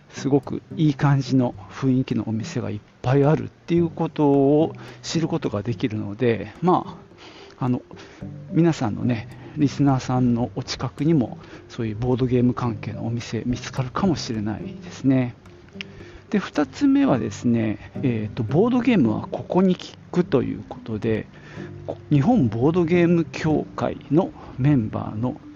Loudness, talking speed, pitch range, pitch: -22 LUFS, 310 characters per minute, 115-150 Hz, 125 Hz